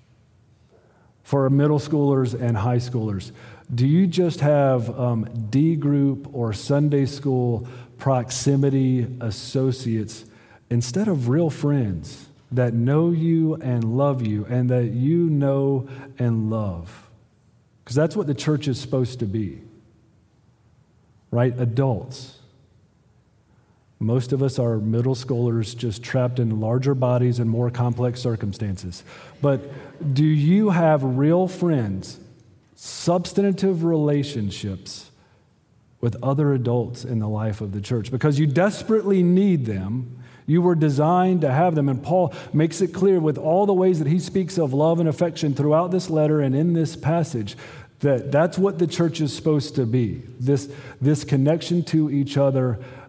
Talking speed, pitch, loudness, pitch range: 140 wpm, 130 Hz, -22 LUFS, 120-150 Hz